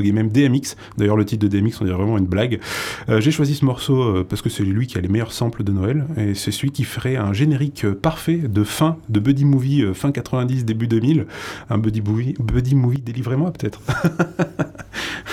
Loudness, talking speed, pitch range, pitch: -20 LUFS, 215 wpm, 105-140 Hz, 120 Hz